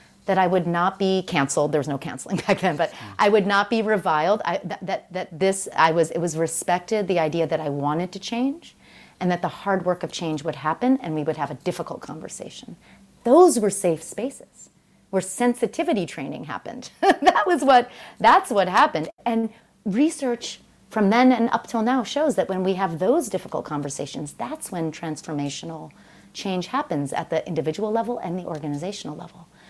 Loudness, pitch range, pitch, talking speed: -23 LUFS, 160-220 Hz, 185 Hz, 190 wpm